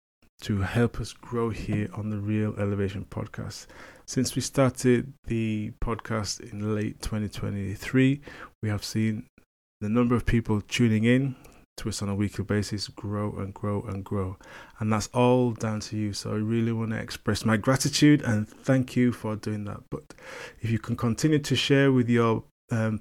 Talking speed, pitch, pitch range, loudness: 175 wpm, 110 Hz, 105-120 Hz, -27 LUFS